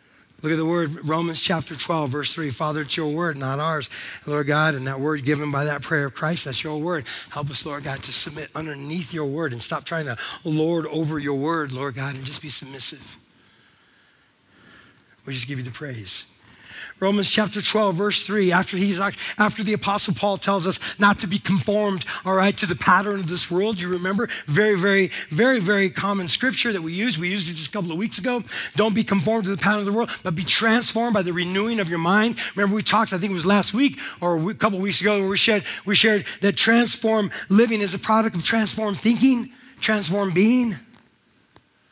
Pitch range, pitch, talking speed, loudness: 155-205 Hz, 185 Hz, 215 wpm, -21 LUFS